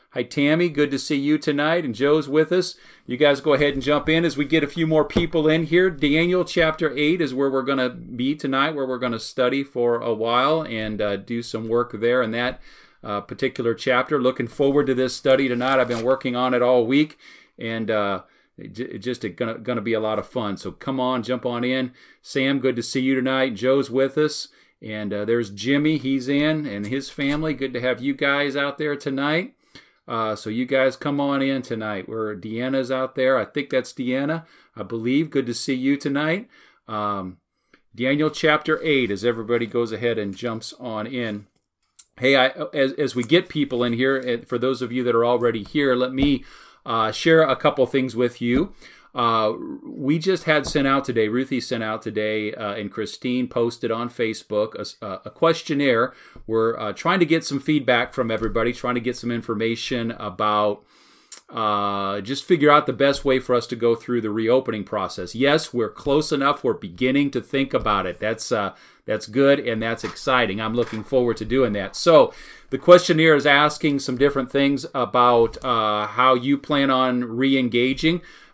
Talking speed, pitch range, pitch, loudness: 200 wpm, 115-145 Hz, 130 Hz, -22 LUFS